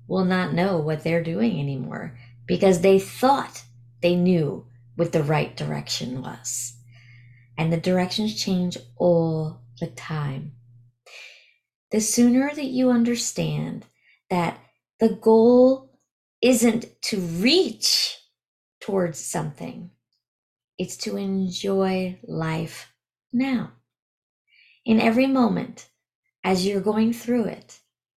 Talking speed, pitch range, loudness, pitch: 105 wpm, 135-225 Hz, -23 LUFS, 180 Hz